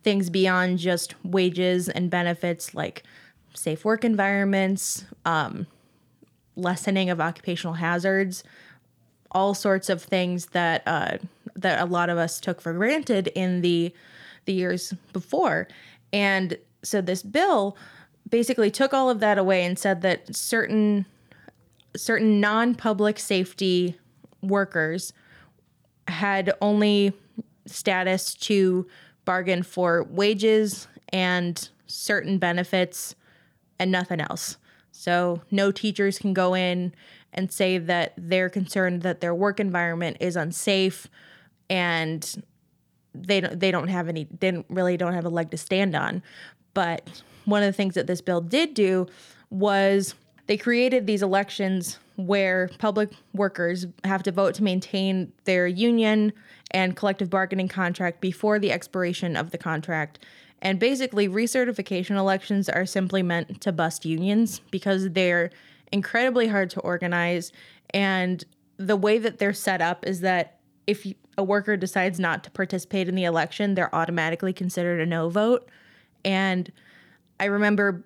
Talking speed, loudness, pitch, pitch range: 135 wpm, -24 LUFS, 190 Hz, 180-200 Hz